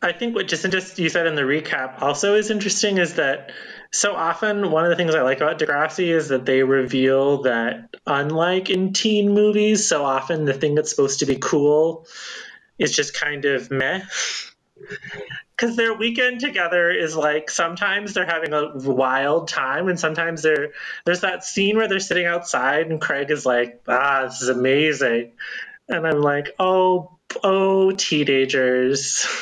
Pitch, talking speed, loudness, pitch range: 160 Hz, 170 wpm, -20 LUFS, 140-190 Hz